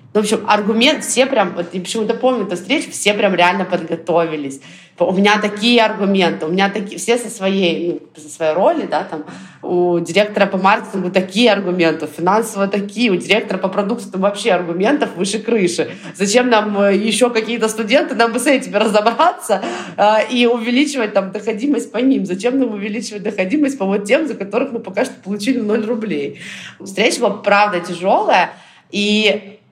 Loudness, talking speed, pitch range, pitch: -16 LUFS, 175 wpm, 185-230 Hz, 210 Hz